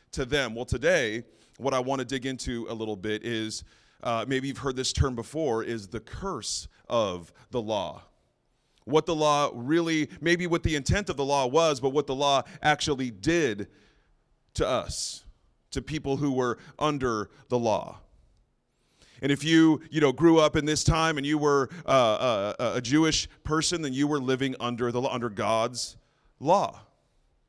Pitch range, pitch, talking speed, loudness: 120-150 Hz, 135 Hz, 175 wpm, -27 LUFS